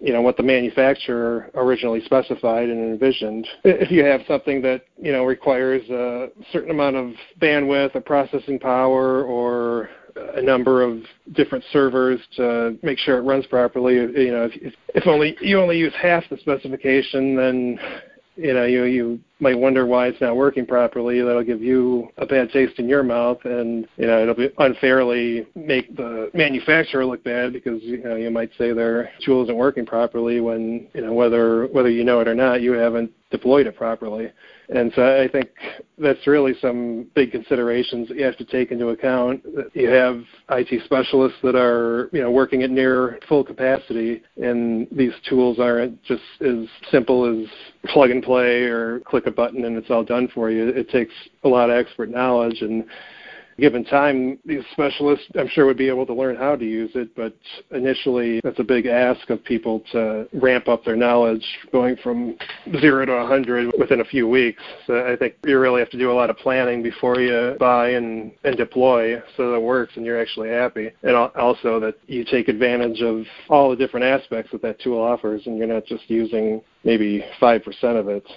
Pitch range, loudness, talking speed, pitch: 115-130 Hz, -20 LUFS, 190 wpm, 125 Hz